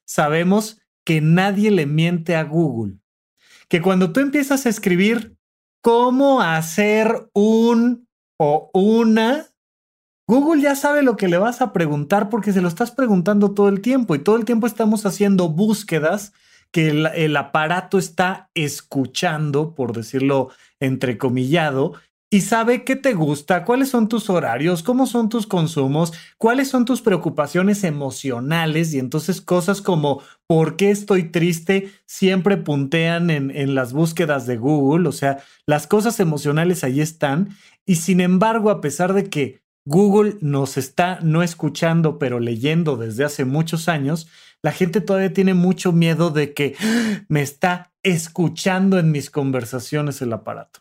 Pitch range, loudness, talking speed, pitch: 150-205 Hz, -19 LUFS, 150 wpm, 180 Hz